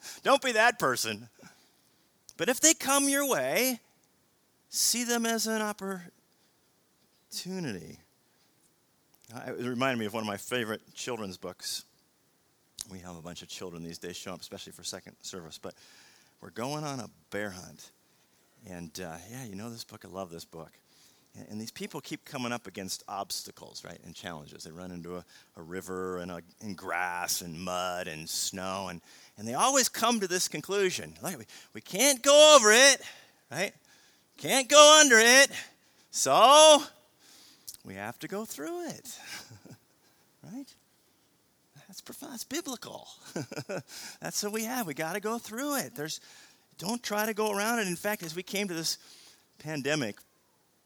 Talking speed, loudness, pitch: 165 wpm, -26 LUFS, 155 Hz